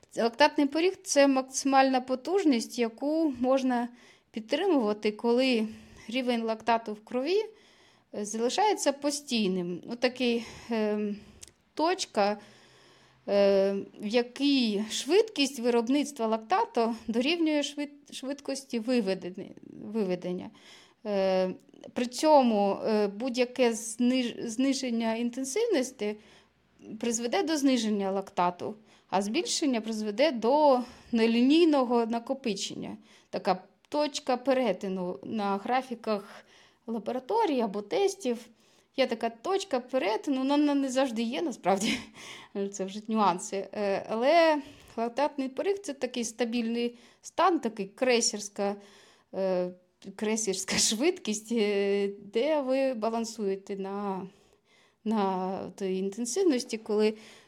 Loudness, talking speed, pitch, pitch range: -29 LUFS, 90 wpm, 235 Hz, 210-270 Hz